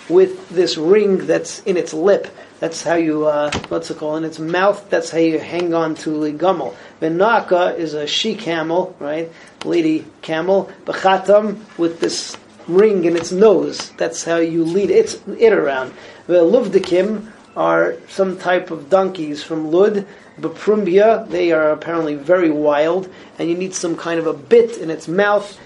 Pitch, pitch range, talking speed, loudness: 175 Hz, 160-200 Hz, 170 wpm, -17 LUFS